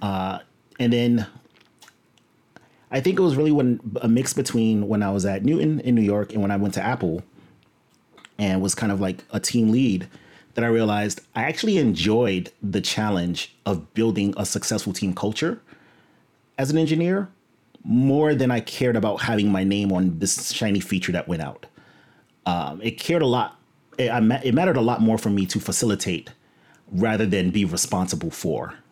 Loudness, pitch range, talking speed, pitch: -22 LUFS, 100-125 Hz, 180 wpm, 110 Hz